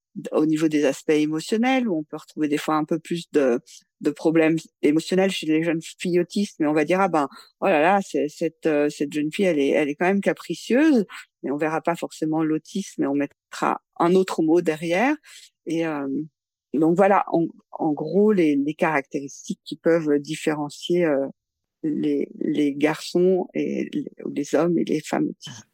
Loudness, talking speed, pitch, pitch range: -23 LUFS, 195 wpm, 160 Hz, 150-180 Hz